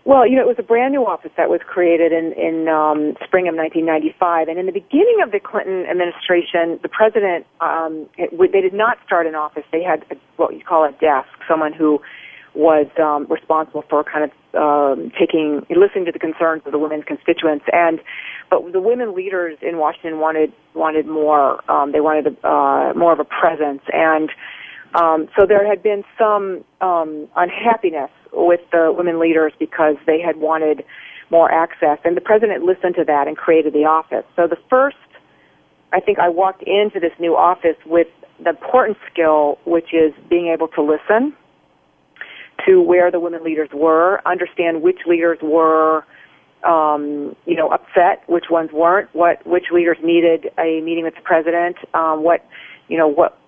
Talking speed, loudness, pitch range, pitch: 185 wpm, -16 LUFS, 155-180 Hz, 165 Hz